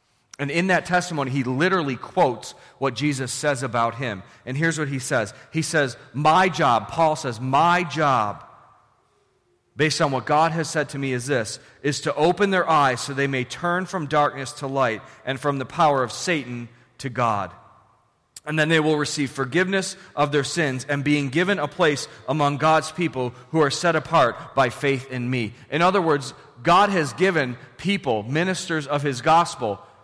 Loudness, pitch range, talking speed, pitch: -22 LUFS, 130-165 Hz, 185 wpm, 145 Hz